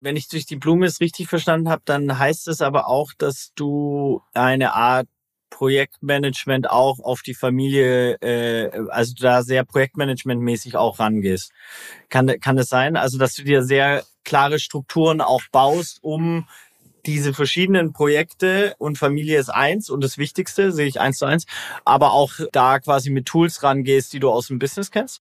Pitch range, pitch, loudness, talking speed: 130-155 Hz, 140 Hz, -19 LUFS, 170 wpm